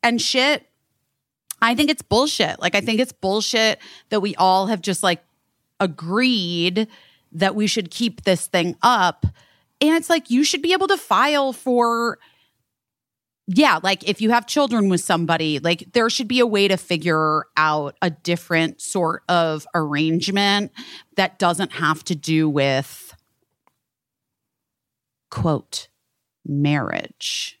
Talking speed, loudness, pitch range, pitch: 140 wpm, -20 LUFS, 165-235 Hz, 190 Hz